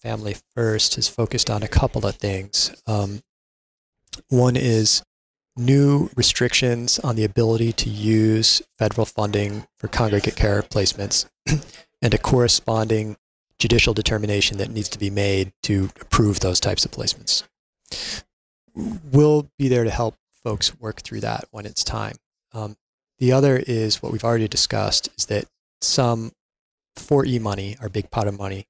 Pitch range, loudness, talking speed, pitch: 105-125 Hz, -21 LUFS, 150 wpm, 110 Hz